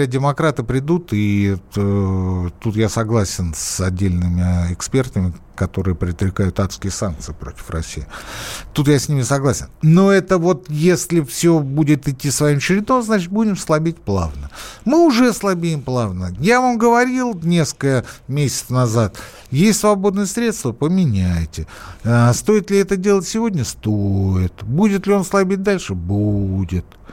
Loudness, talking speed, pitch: -17 LUFS, 130 wpm, 130 Hz